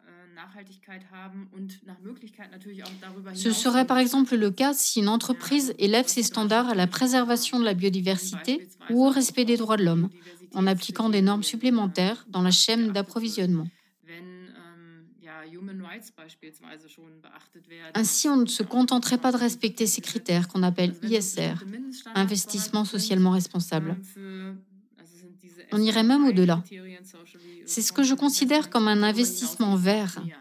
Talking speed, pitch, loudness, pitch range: 125 wpm, 200 Hz, -24 LUFS, 180-230 Hz